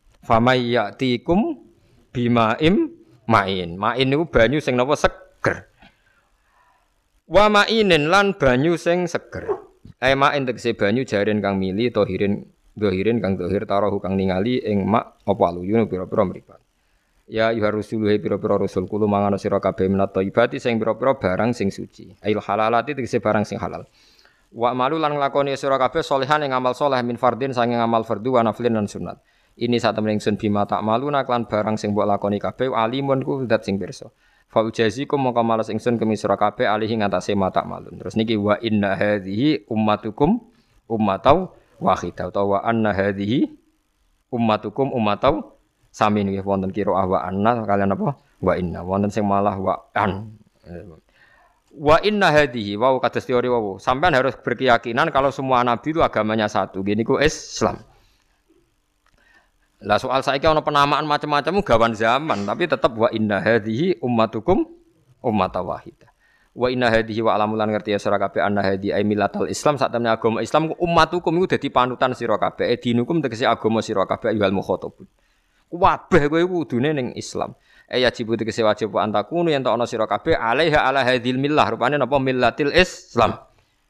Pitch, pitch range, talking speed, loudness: 115 Hz, 105-135 Hz, 160 wpm, -20 LUFS